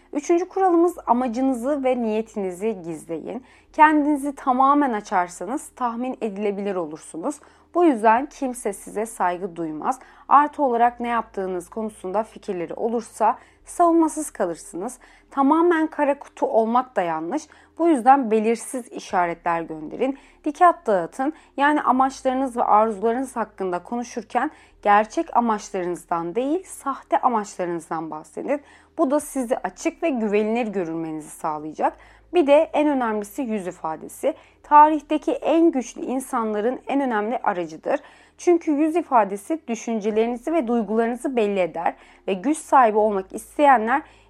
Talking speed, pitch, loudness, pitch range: 115 wpm, 240 Hz, -22 LUFS, 205-290 Hz